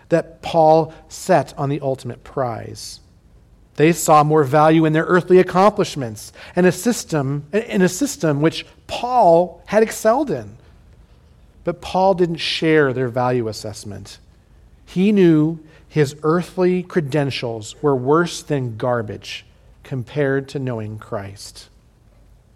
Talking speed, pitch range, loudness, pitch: 120 wpm, 115-170 Hz, -18 LUFS, 150 Hz